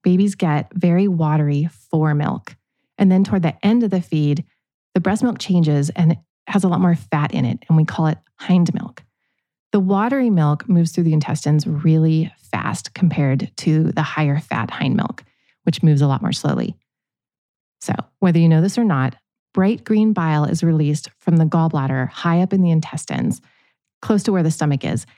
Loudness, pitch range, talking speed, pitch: -18 LUFS, 155-190 Hz, 195 wpm, 165 Hz